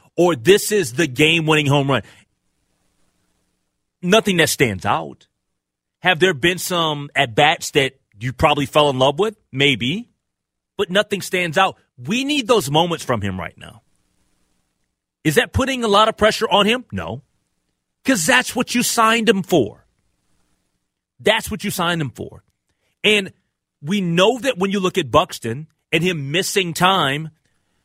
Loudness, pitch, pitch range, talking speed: -18 LUFS, 165 Hz, 130-200 Hz, 160 wpm